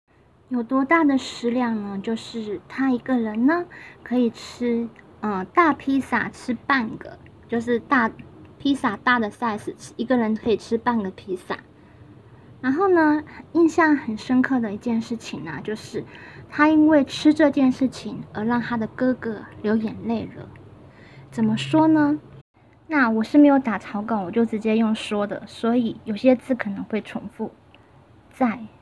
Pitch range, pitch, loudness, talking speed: 220-270 Hz, 240 Hz, -22 LUFS, 230 characters per minute